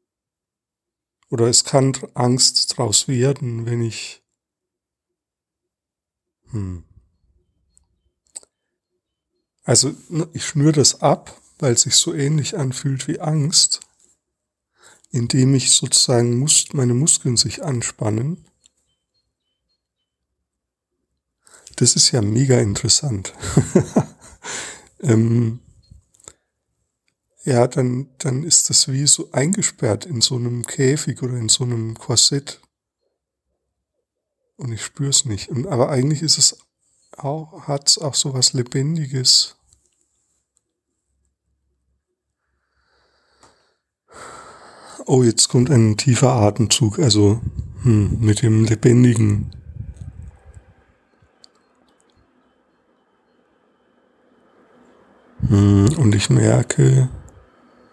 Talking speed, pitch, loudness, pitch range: 85 wpm, 125 Hz, -17 LUFS, 105-140 Hz